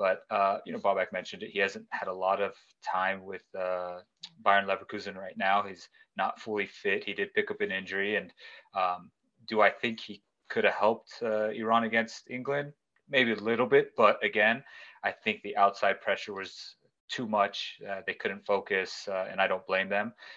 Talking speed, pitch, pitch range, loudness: 195 wpm, 110 Hz, 95-140 Hz, -30 LUFS